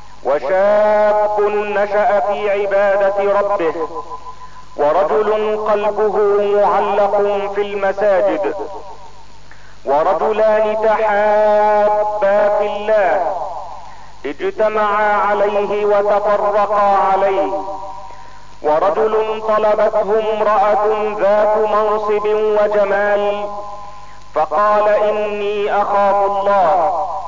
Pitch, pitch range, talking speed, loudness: 205 Hz, 200-210 Hz, 60 wpm, -15 LUFS